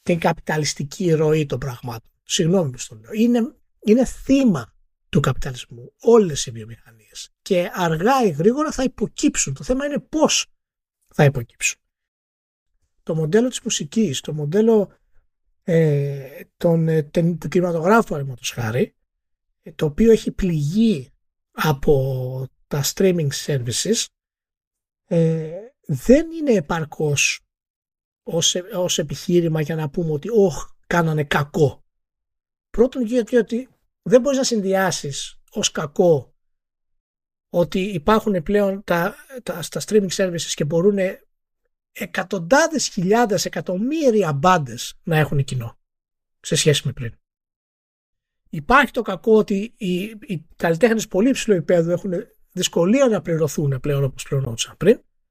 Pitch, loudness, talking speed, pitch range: 175 Hz, -20 LUFS, 115 wpm, 145-215 Hz